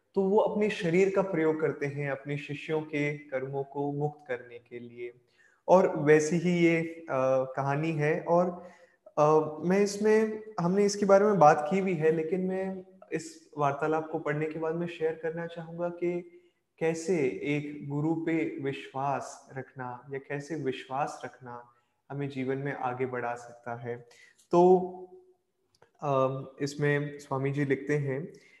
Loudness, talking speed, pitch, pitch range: -29 LUFS, 155 wpm, 155 Hz, 135-175 Hz